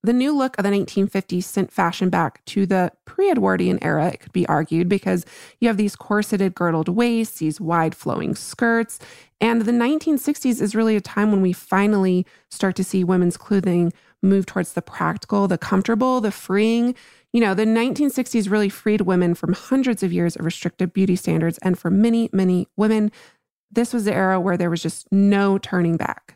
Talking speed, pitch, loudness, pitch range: 185 wpm, 195 Hz, -20 LUFS, 180-225 Hz